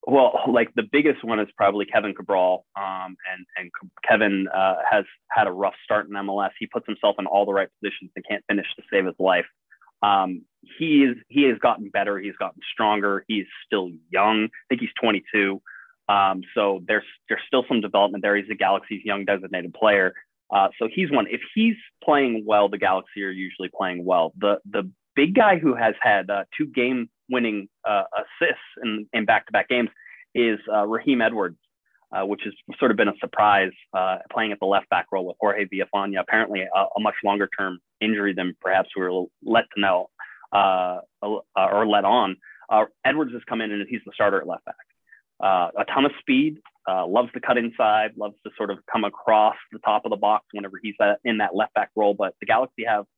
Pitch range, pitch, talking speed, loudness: 95-115 Hz, 100 Hz, 205 wpm, -23 LUFS